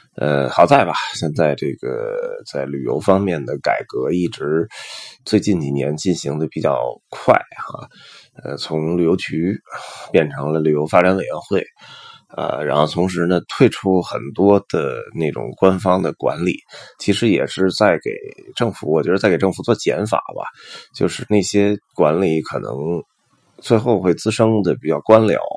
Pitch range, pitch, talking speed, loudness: 85-110 Hz, 95 Hz, 235 characters per minute, -18 LUFS